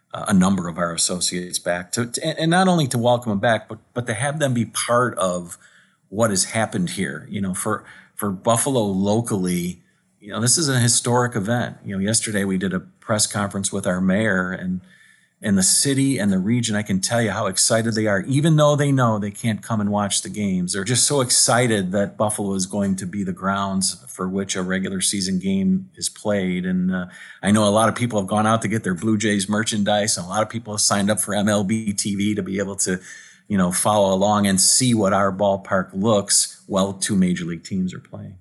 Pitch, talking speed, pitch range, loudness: 105 Hz, 225 wpm, 95-120 Hz, -20 LUFS